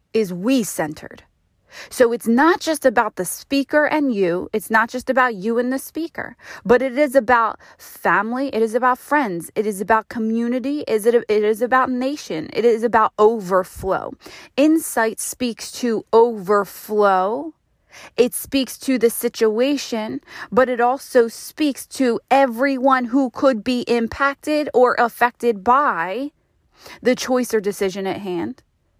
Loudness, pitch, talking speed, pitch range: -19 LUFS, 240 Hz, 145 wpm, 220-265 Hz